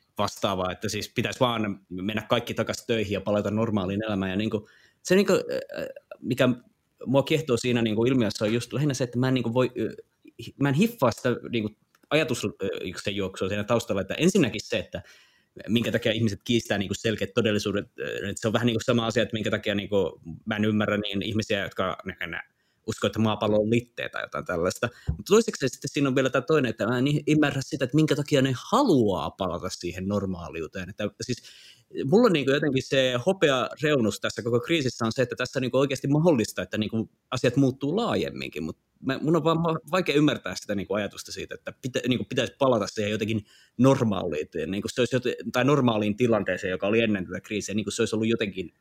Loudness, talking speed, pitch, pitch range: -26 LUFS, 205 wpm, 115 Hz, 105-135 Hz